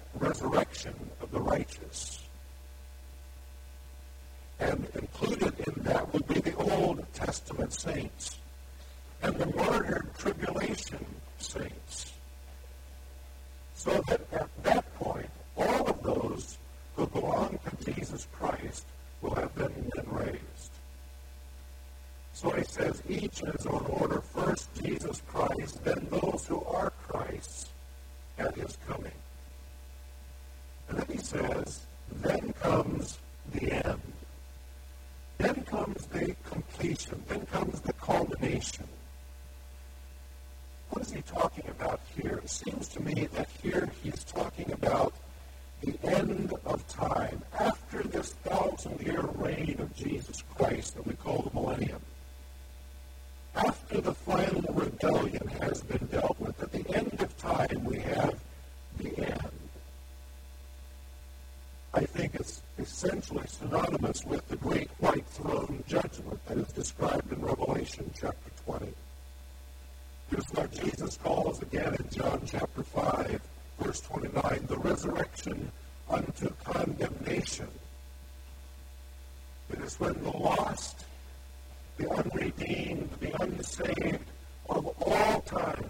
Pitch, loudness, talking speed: 65 Hz, -34 LUFS, 115 wpm